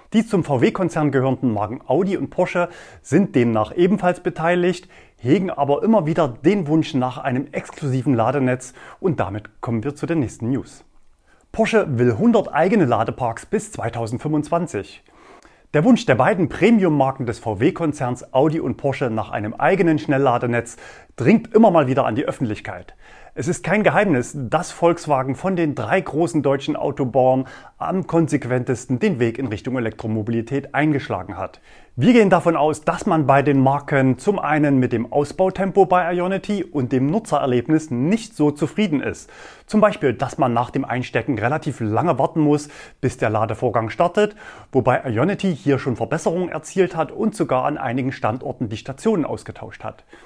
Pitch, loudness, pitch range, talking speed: 145 Hz, -20 LUFS, 125-175 Hz, 160 wpm